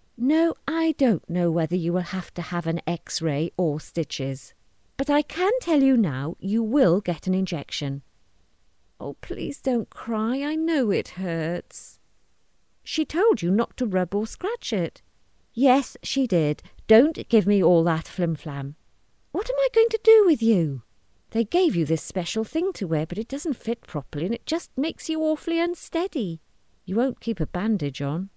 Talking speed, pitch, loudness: 180 wpm, 205 Hz, -24 LUFS